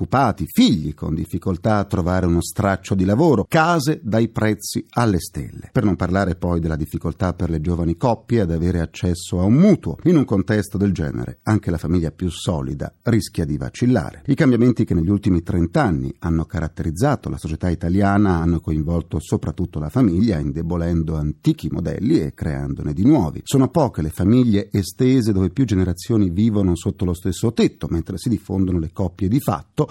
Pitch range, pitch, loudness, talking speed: 85-110 Hz, 95 Hz, -20 LUFS, 175 wpm